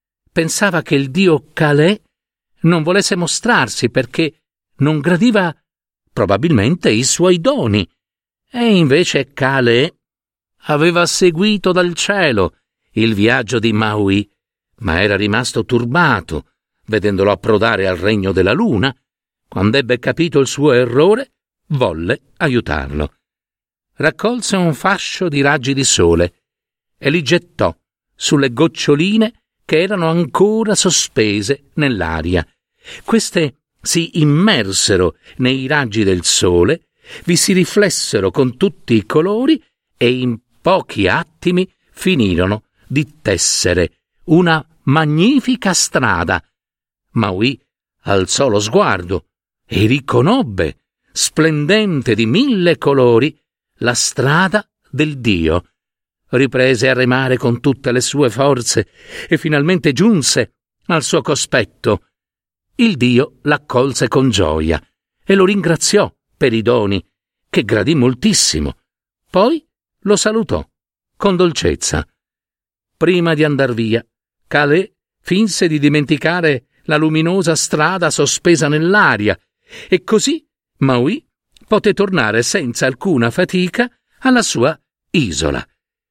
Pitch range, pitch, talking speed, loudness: 120-180 Hz, 150 Hz, 110 wpm, -14 LUFS